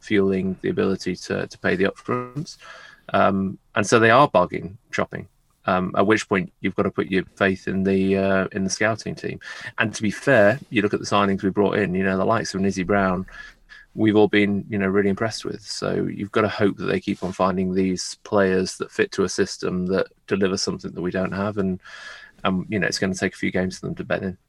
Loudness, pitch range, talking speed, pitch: -22 LUFS, 95-100 Hz, 245 wpm, 95 Hz